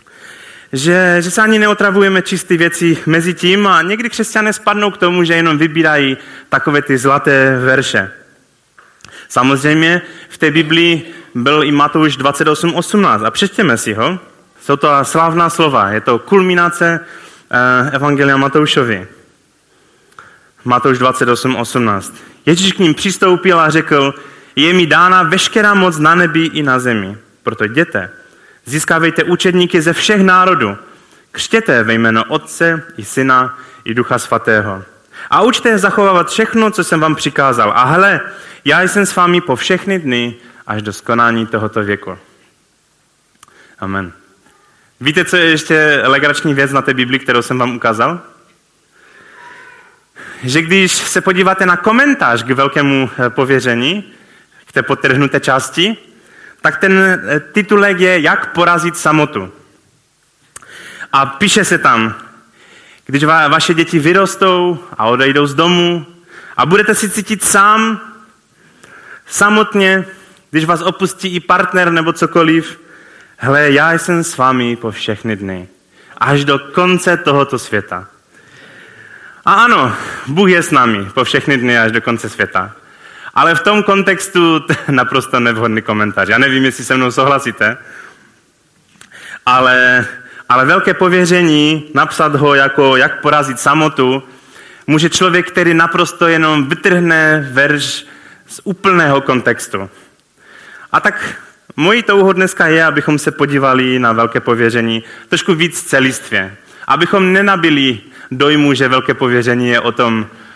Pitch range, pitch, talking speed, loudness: 130-180 Hz, 155 Hz, 130 wpm, -11 LUFS